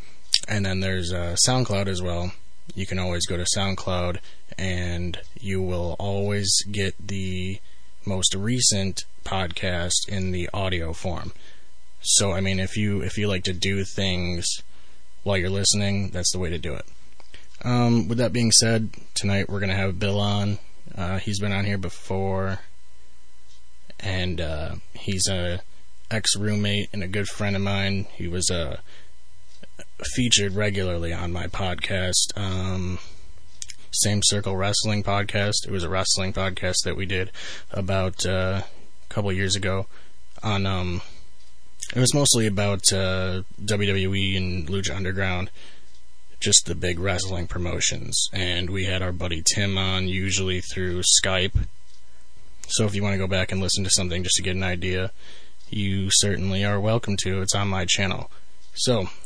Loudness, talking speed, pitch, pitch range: -24 LUFS, 155 wpm, 95 Hz, 90-100 Hz